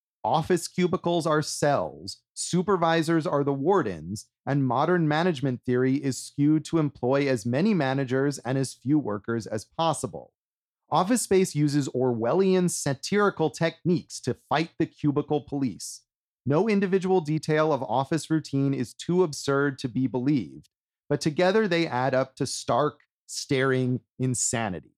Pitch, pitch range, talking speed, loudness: 145 Hz, 130-165 Hz, 135 wpm, -26 LUFS